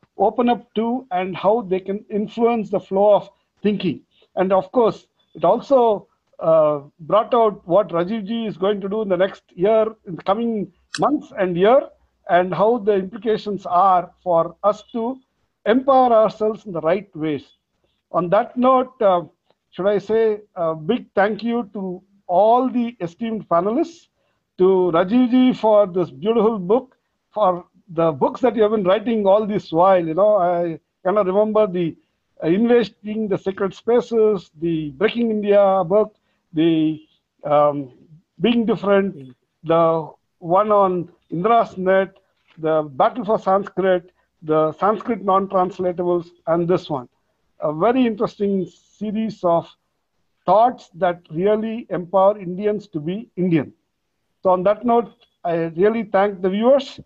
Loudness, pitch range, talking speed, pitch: -19 LUFS, 175-220 Hz, 145 wpm, 195 Hz